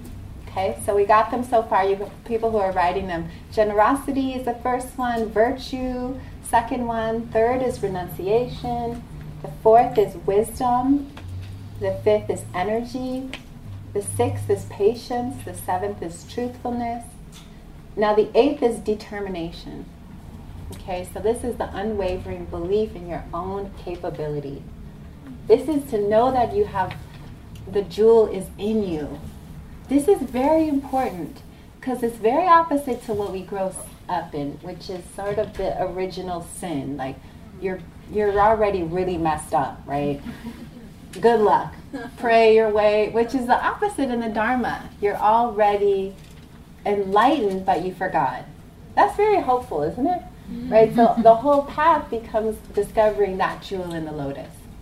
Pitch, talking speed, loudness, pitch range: 215 Hz, 145 wpm, -22 LUFS, 180-245 Hz